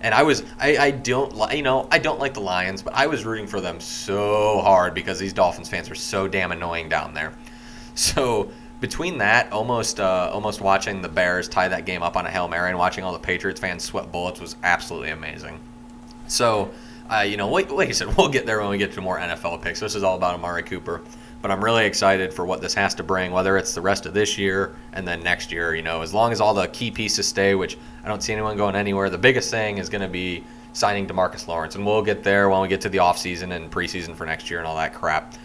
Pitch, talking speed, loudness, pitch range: 95 Hz, 250 wpm, -22 LUFS, 90-110 Hz